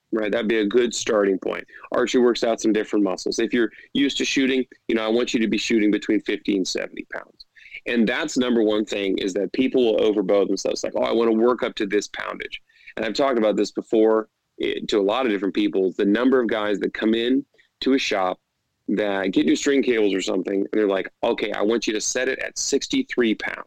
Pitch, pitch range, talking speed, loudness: 115 Hz, 105-135 Hz, 245 wpm, -22 LUFS